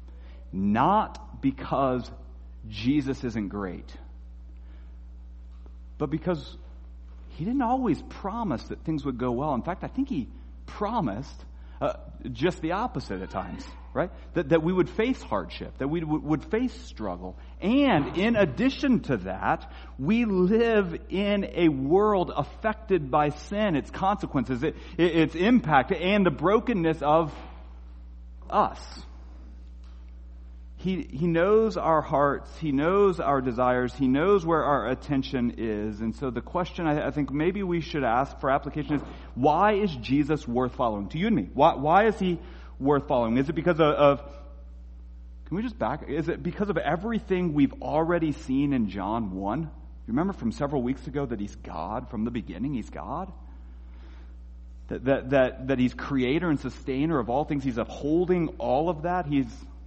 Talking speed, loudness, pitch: 160 wpm, -26 LUFS, 140 Hz